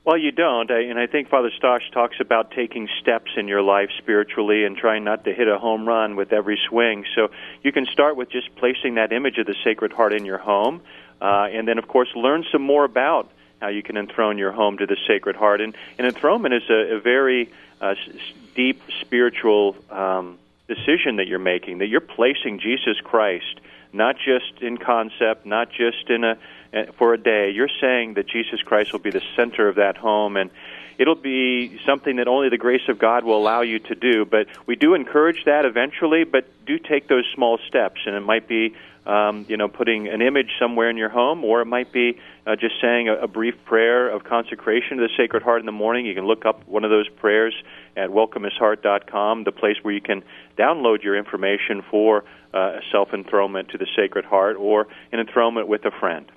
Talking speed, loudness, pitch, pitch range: 215 wpm, -20 LUFS, 115 Hz, 105-125 Hz